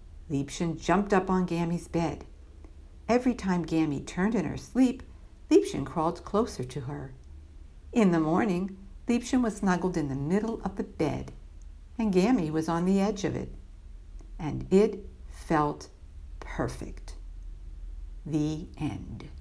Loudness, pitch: -29 LUFS, 155 Hz